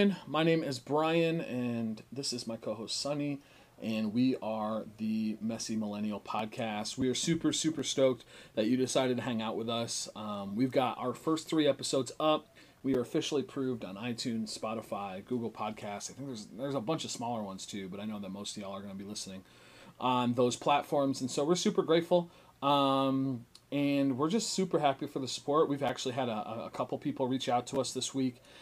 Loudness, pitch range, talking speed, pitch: -33 LUFS, 110-145 Hz, 210 wpm, 130 Hz